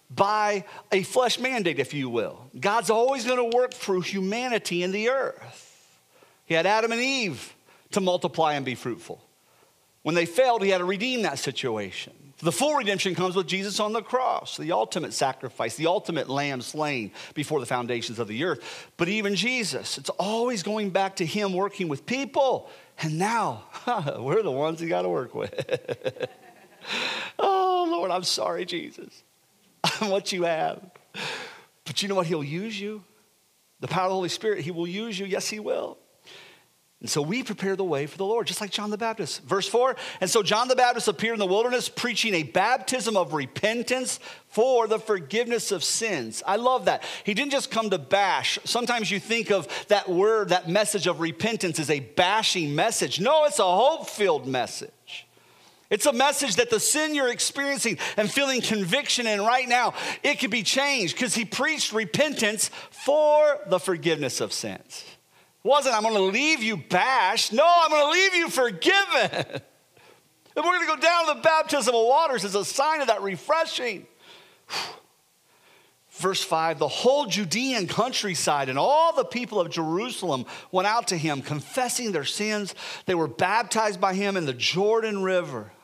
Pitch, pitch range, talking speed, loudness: 210 Hz, 180-255 Hz, 175 wpm, -25 LUFS